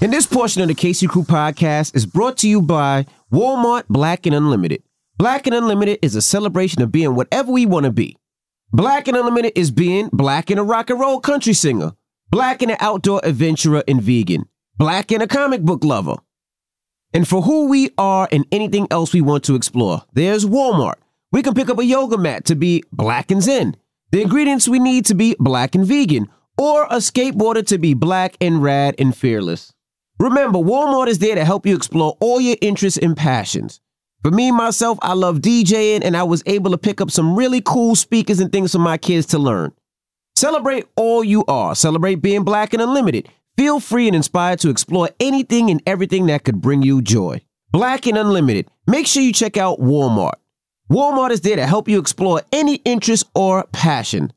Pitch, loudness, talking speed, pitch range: 190 Hz, -16 LUFS, 200 wpm, 155-235 Hz